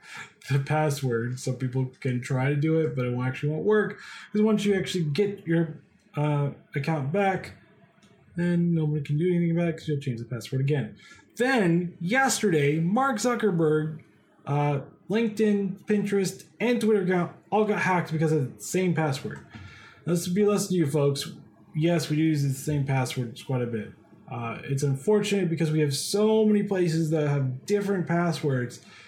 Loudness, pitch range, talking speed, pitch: -26 LUFS, 140-195 Hz, 170 wpm, 165 Hz